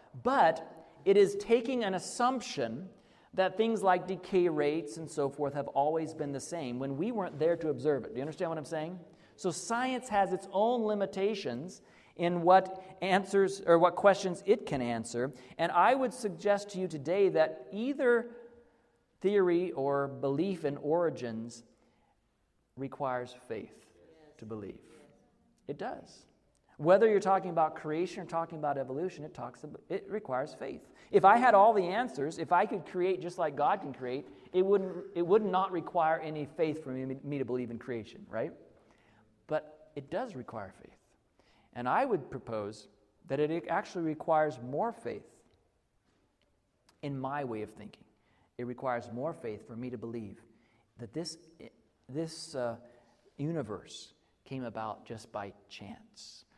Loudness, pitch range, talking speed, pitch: -32 LUFS, 130-190 Hz, 160 wpm, 160 Hz